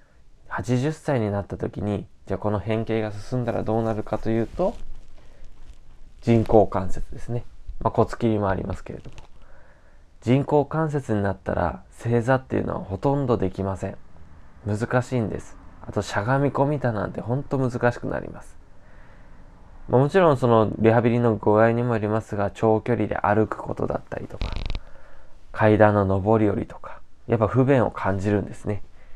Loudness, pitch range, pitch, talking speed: -23 LUFS, 95-120 Hz, 110 Hz, 330 characters per minute